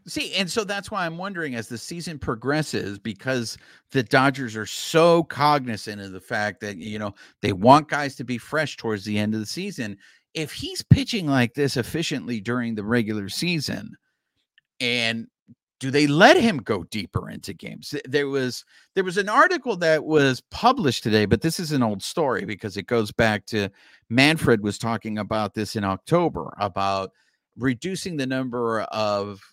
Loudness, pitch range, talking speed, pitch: -23 LUFS, 110-155 Hz, 175 wpm, 125 Hz